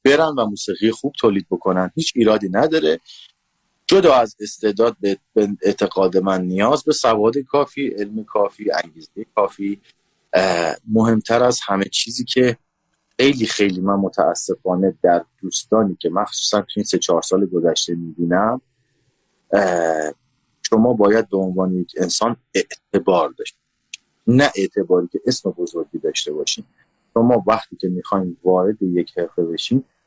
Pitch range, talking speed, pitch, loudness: 95-125 Hz, 130 wpm, 105 Hz, -19 LUFS